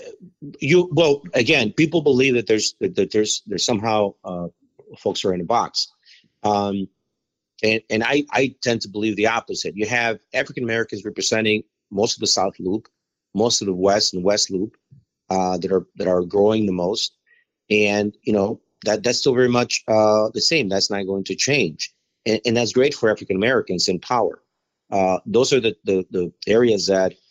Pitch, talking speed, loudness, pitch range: 110 Hz, 180 wpm, -20 LUFS, 95-120 Hz